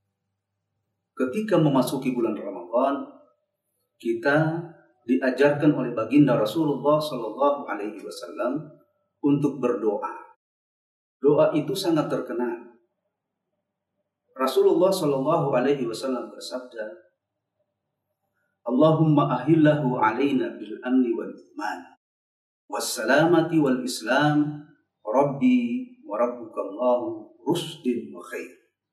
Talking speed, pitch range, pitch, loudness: 85 wpm, 125-165 Hz, 145 Hz, -24 LUFS